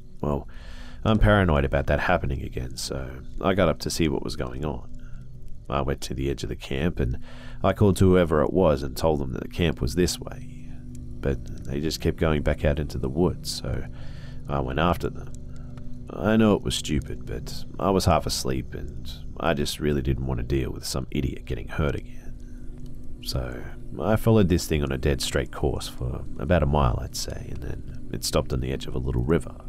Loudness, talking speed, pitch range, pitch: -26 LUFS, 215 wpm, 65-85 Hz, 70 Hz